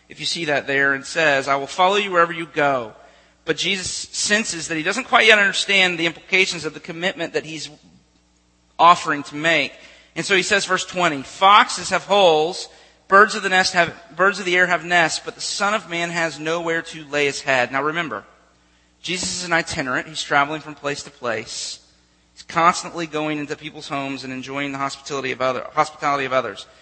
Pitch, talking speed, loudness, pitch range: 155 Hz, 205 wpm, -19 LUFS, 140-180 Hz